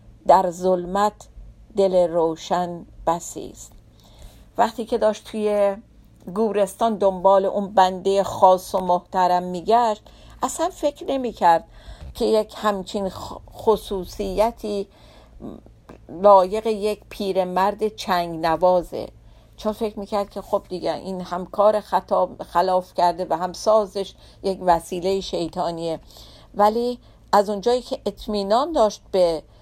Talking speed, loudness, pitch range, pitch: 110 wpm, -21 LUFS, 180-215 Hz, 195 Hz